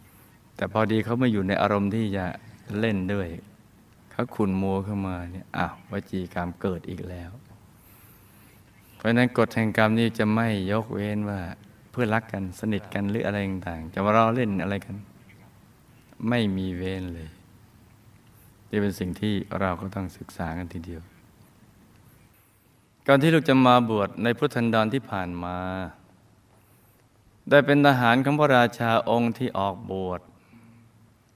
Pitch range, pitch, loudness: 95-115 Hz, 105 Hz, -25 LUFS